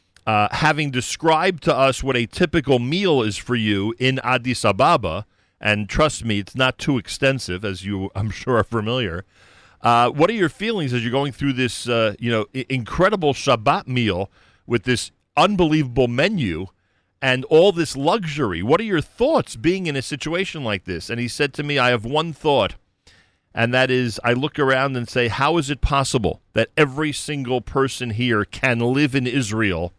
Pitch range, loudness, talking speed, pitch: 105-145 Hz, -20 LUFS, 185 wpm, 125 Hz